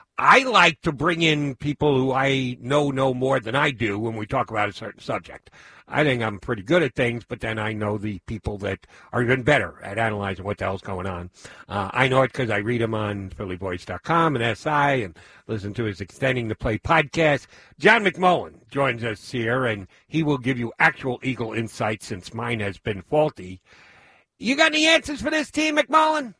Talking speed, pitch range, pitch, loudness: 205 wpm, 105-145 Hz, 120 Hz, -22 LUFS